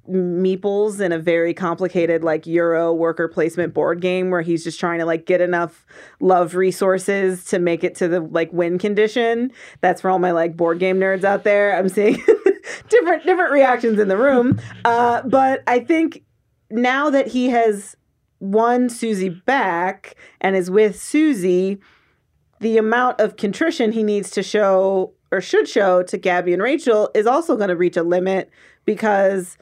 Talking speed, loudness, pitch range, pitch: 170 wpm, -18 LUFS, 180-235 Hz, 195 Hz